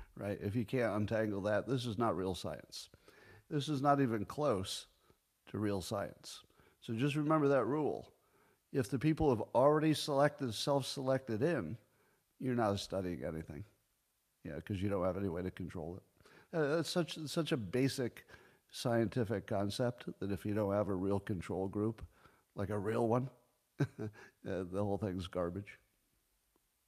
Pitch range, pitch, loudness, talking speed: 100-135 Hz, 110 Hz, -37 LUFS, 165 wpm